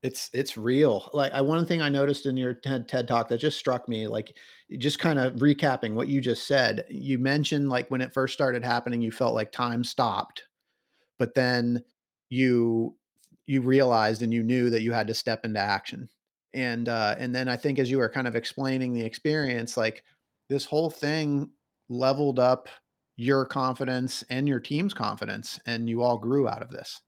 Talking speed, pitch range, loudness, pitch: 195 wpm, 120-140 Hz, -27 LUFS, 130 Hz